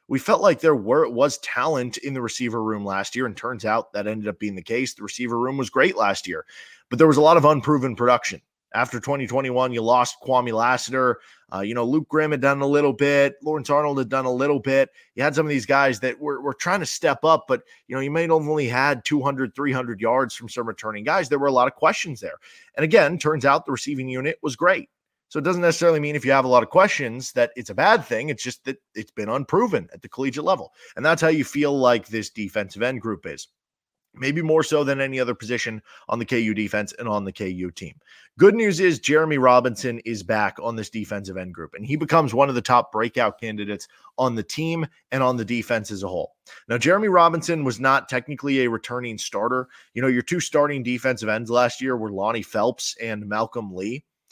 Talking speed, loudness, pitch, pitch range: 235 wpm, -22 LUFS, 130 Hz, 115-145 Hz